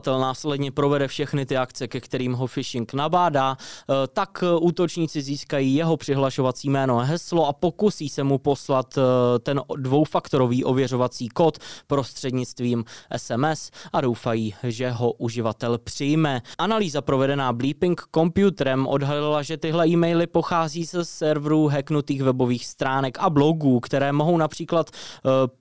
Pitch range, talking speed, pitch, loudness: 130-160 Hz, 125 wpm, 140 Hz, -23 LUFS